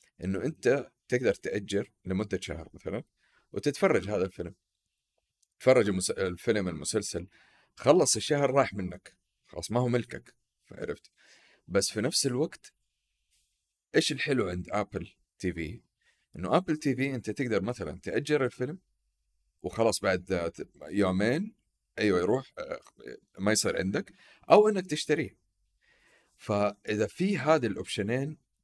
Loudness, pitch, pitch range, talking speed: -29 LUFS, 105 Hz, 90-130 Hz, 115 wpm